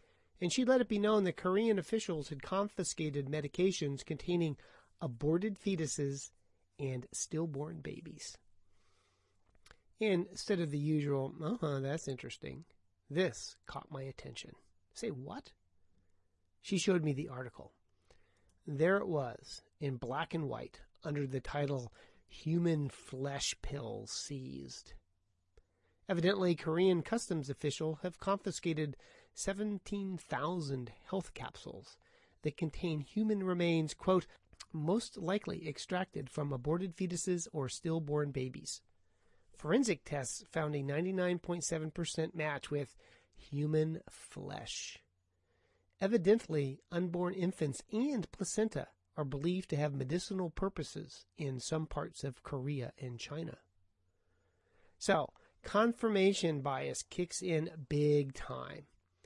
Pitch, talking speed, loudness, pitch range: 155 Hz, 110 wpm, -37 LUFS, 135-180 Hz